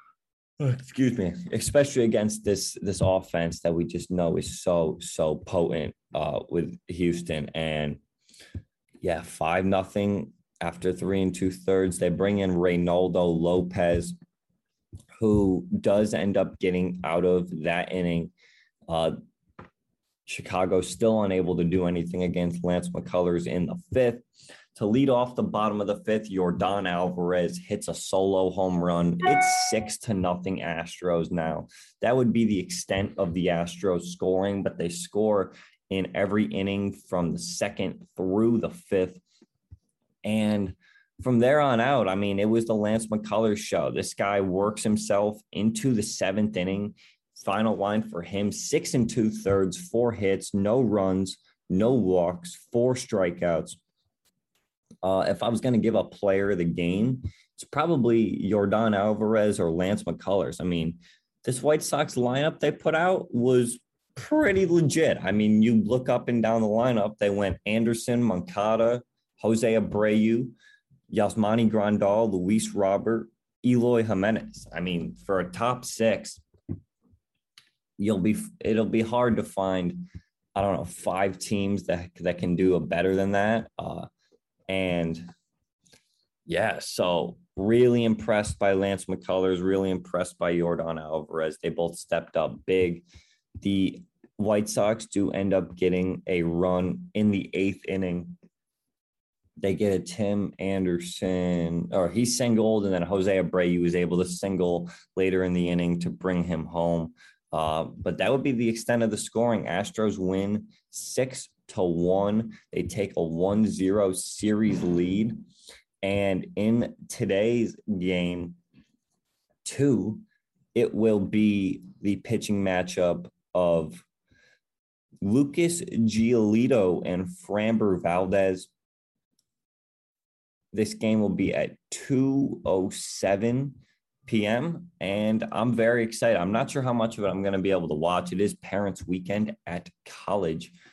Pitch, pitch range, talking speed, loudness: 100 Hz, 90-110 Hz, 145 wpm, -26 LUFS